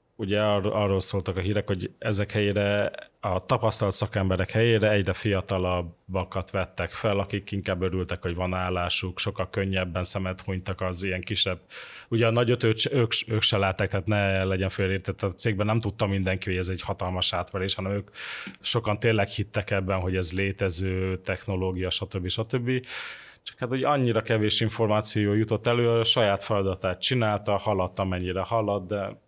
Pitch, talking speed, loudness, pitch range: 100 Hz, 160 wpm, -26 LUFS, 95-110 Hz